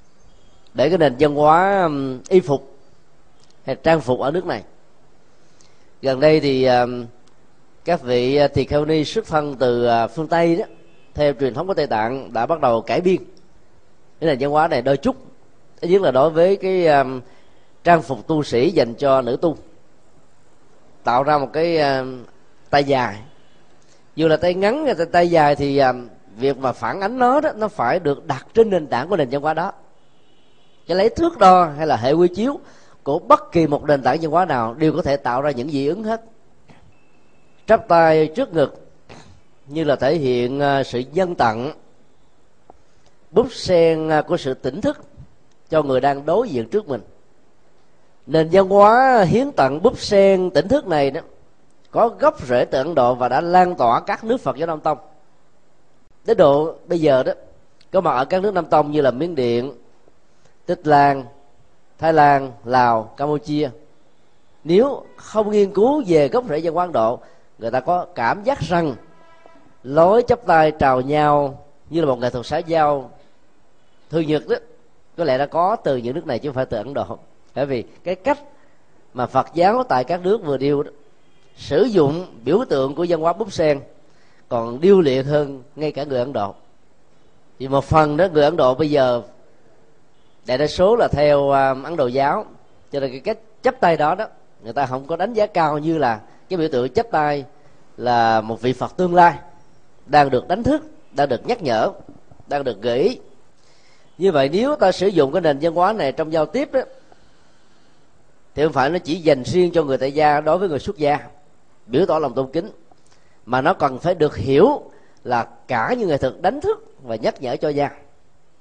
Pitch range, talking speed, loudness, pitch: 135-180 Hz, 190 wpm, -18 LUFS, 150 Hz